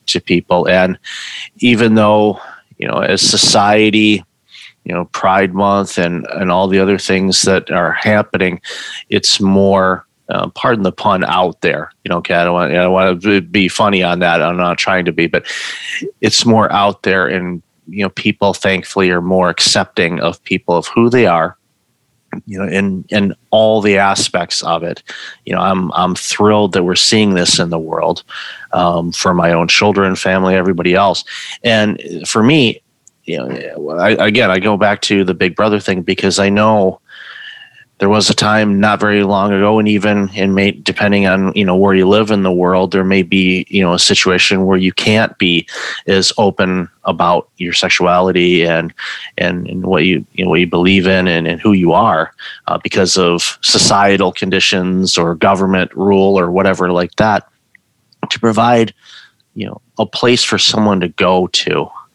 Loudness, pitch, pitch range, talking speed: -12 LUFS, 95 Hz, 90-105 Hz, 185 wpm